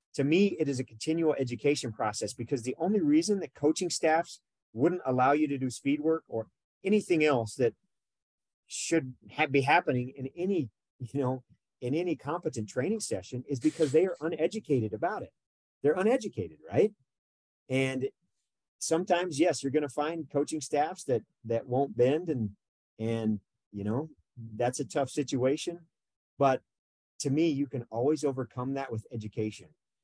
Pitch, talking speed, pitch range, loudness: 140 Hz, 160 wpm, 125-160 Hz, -30 LUFS